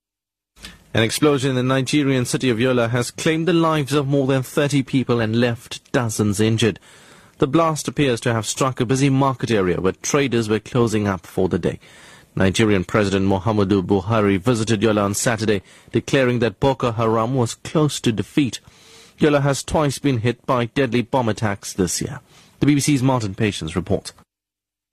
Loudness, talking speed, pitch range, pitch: -20 LUFS, 170 wpm, 105-140 Hz, 120 Hz